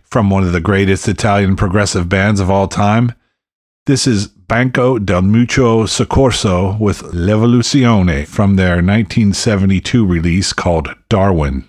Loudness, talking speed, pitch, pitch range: -13 LUFS, 130 wpm, 100 Hz, 95-115 Hz